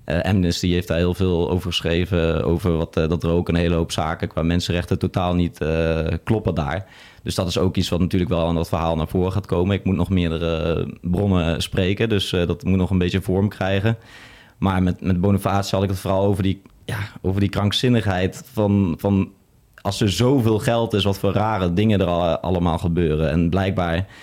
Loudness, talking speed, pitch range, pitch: -21 LUFS, 210 wpm, 85-100 Hz, 95 Hz